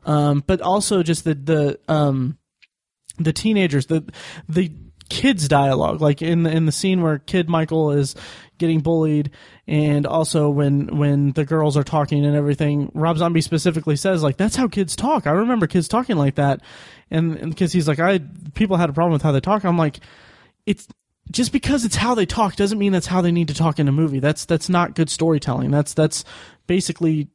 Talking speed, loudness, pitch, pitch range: 195 wpm, -19 LUFS, 160 Hz, 145-180 Hz